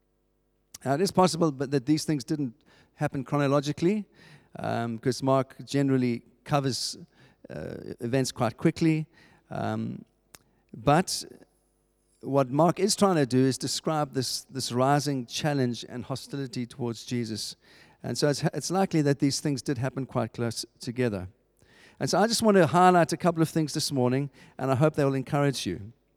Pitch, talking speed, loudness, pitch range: 140 Hz, 165 wpm, -27 LUFS, 125-155 Hz